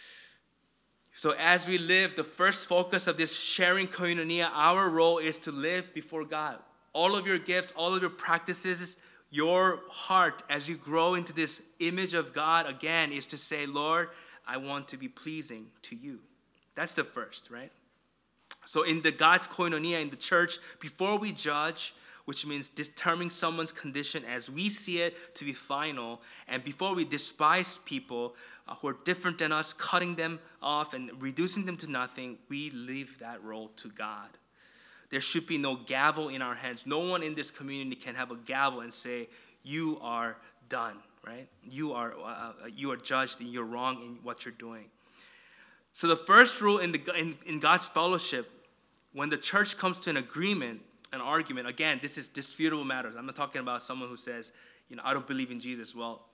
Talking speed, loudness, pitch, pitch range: 185 wpm, -29 LUFS, 155 Hz, 135-175 Hz